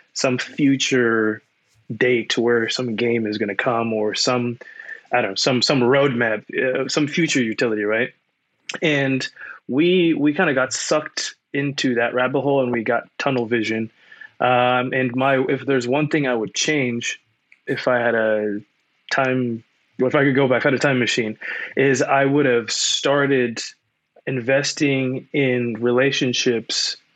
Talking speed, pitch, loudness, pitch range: 160 wpm, 130 Hz, -20 LUFS, 120-140 Hz